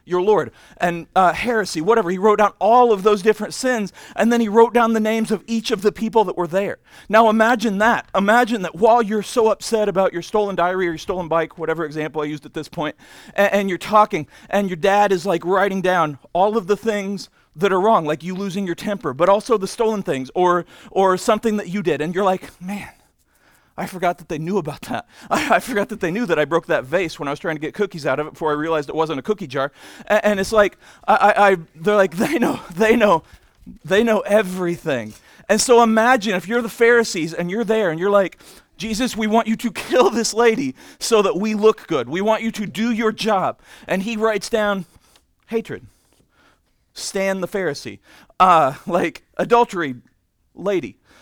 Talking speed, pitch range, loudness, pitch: 220 wpm, 175-220 Hz, -19 LUFS, 200 Hz